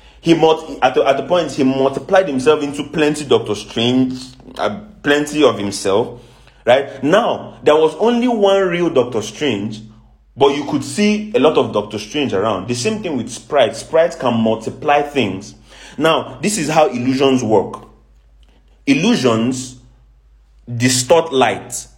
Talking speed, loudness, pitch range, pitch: 150 wpm, -16 LUFS, 110-160 Hz, 130 Hz